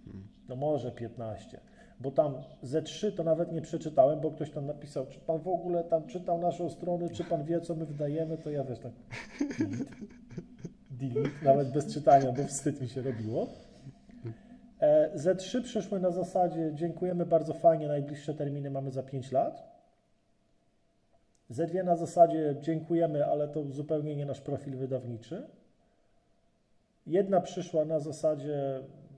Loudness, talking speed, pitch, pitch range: -31 LUFS, 145 wpm, 155 Hz, 140-175 Hz